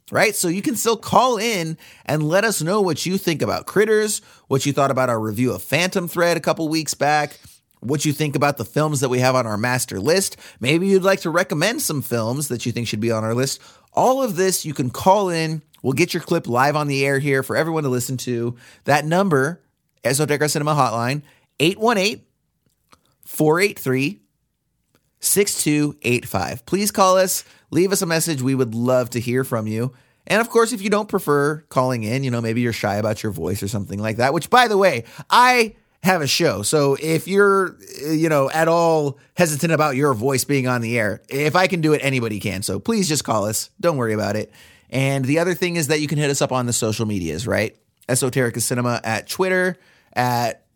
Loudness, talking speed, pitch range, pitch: -20 LUFS, 215 wpm, 125-175 Hz, 145 Hz